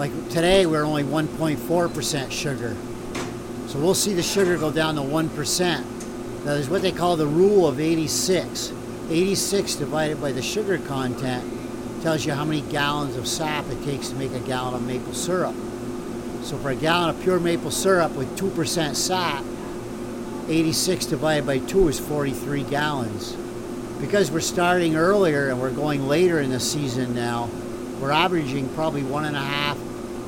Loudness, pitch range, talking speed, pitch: -23 LUFS, 120-165 Hz, 170 wpm, 145 Hz